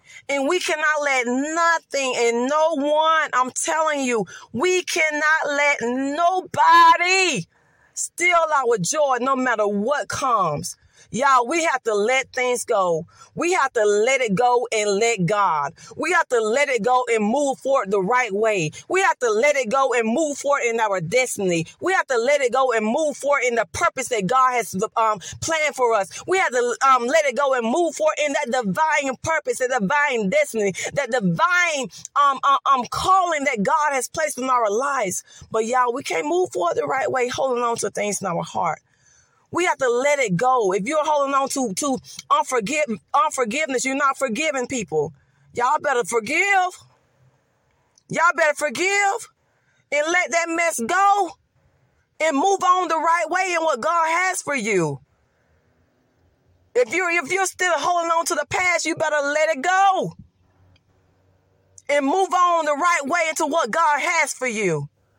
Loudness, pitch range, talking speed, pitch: -20 LUFS, 235-330 Hz, 180 wpm, 285 Hz